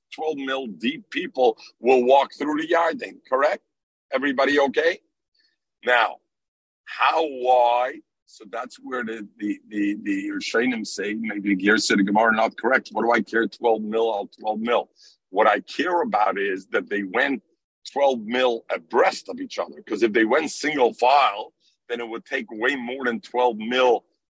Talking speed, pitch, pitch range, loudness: 175 wpm, 125 Hz, 110-140 Hz, -22 LUFS